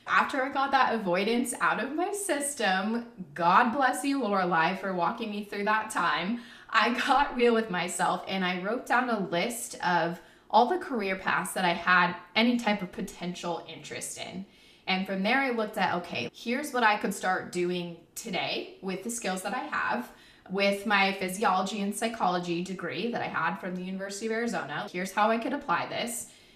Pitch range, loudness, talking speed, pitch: 180-230 Hz, -28 LUFS, 190 wpm, 200 Hz